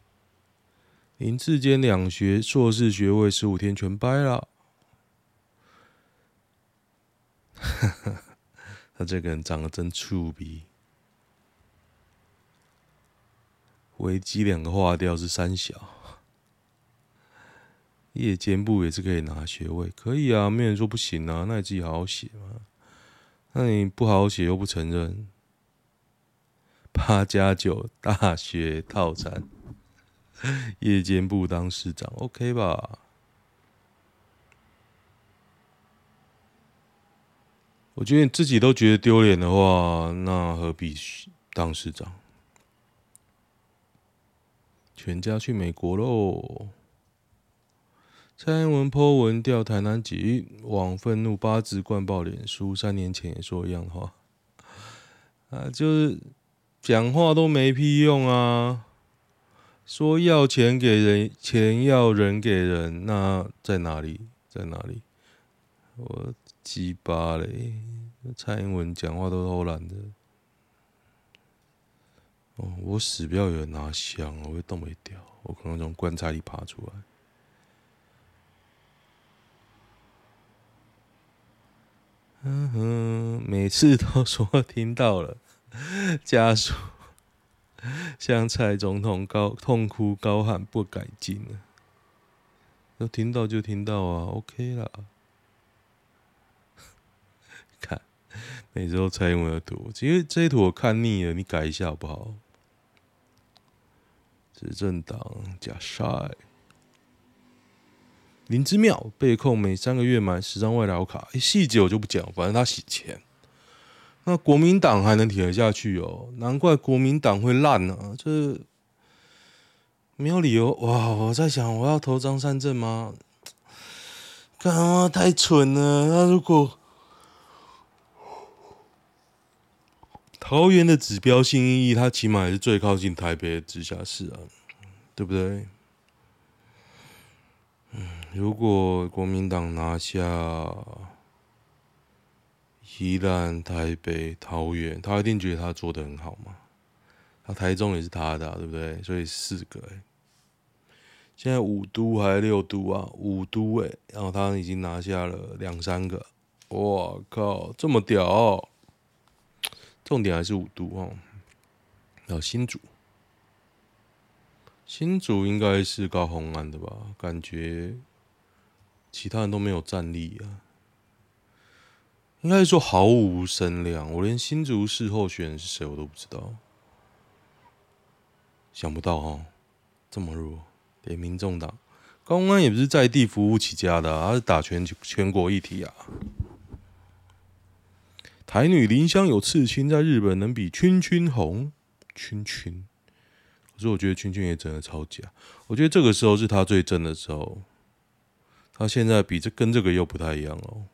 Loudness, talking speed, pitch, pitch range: -24 LUFS, 175 characters per minute, 105 Hz, 90-120 Hz